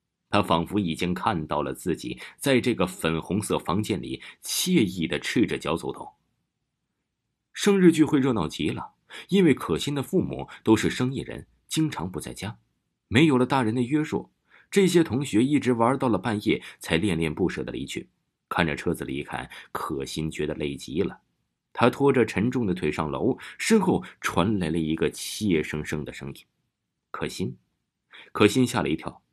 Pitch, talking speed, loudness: 90 Hz, 250 characters per minute, -25 LUFS